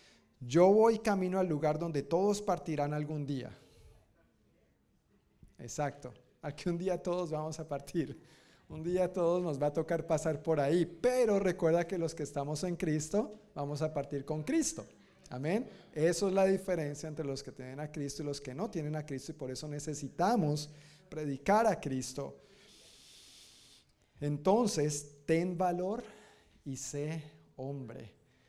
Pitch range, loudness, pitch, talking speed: 145-180 Hz, -34 LUFS, 155 Hz, 150 wpm